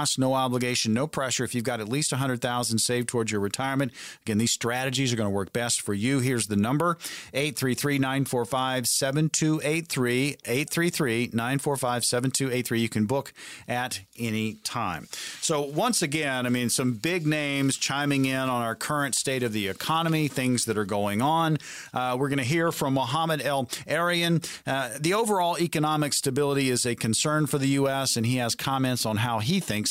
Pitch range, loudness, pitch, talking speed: 120-145 Hz, -26 LUFS, 130 Hz, 180 wpm